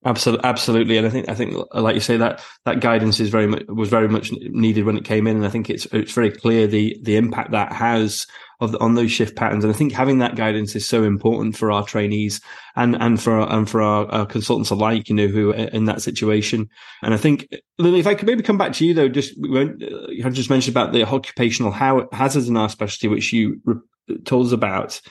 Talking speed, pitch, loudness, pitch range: 235 wpm, 115 Hz, -19 LUFS, 110-125 Hz